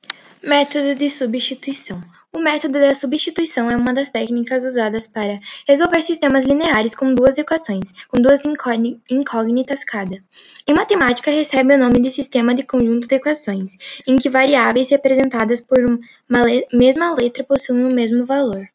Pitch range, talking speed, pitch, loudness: 240-280 Hz, 150 wpm, 260 Hz, -17 LUFS